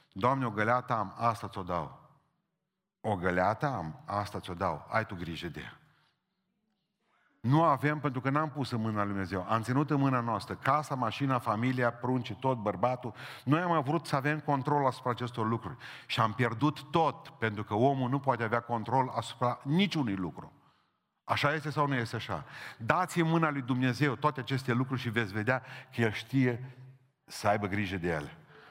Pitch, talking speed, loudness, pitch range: 125 Hz, 180 wpm, -31 LUFS, 110-145 Hz